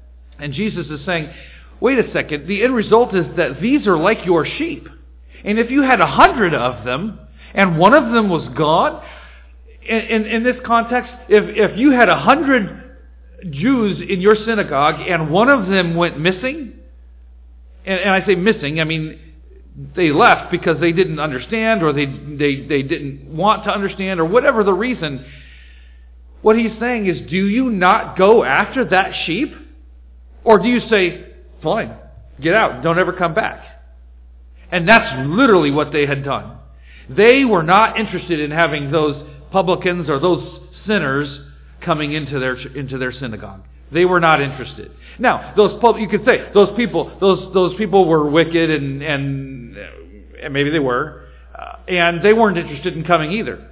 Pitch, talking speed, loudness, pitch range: 170 Hz, 170 wpm, -16 LUFS, 135-210 Hz